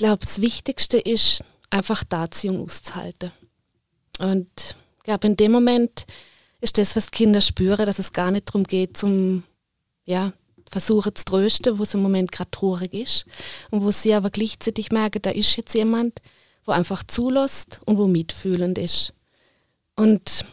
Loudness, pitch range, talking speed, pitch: -20 LUFS, 185-220 Hz, 165 wpm, 205 Hz